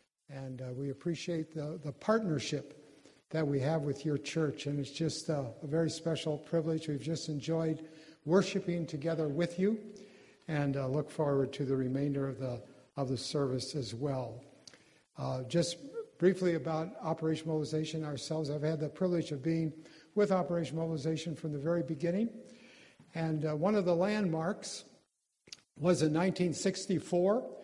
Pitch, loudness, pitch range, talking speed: 160 Hz, -34 LUFS, 145-170 Hz, 155 wpm